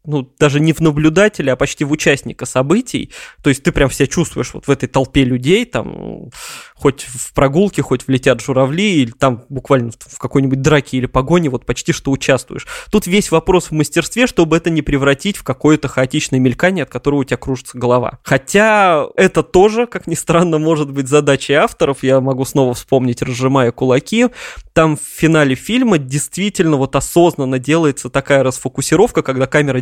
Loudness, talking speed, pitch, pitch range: -14 LUFS, 175 wpm, 145 Hz, 130-170 Hz